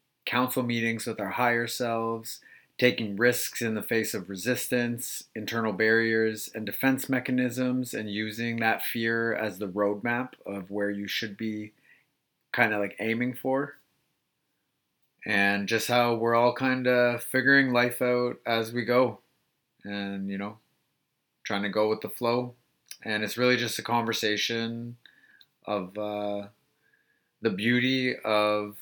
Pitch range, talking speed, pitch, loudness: 105-125 Hz, 140 wpm, 115 Hz, -27 LUFS